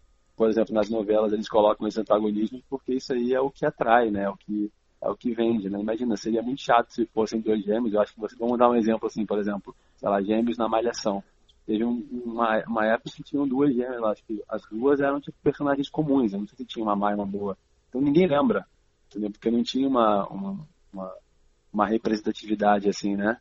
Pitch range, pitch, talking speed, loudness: 105-125 Hz, 110 Hz, 220 wpm, -25 LUFS